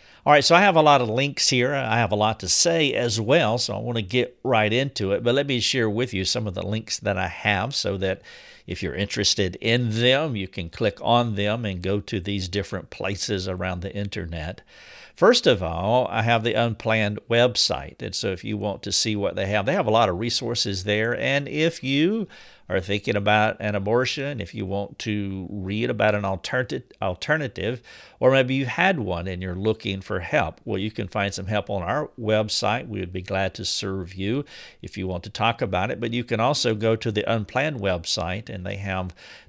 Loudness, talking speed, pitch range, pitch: -23 LUFS, 225 wpm, 100-120 Hz, 105 Hz